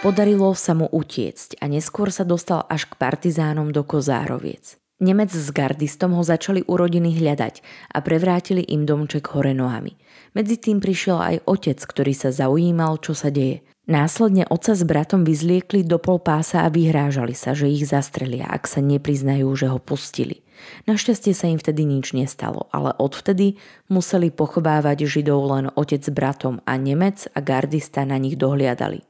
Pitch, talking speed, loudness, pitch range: 155 Hz, 165 wpm, -20 LUFS, 140-180 Hz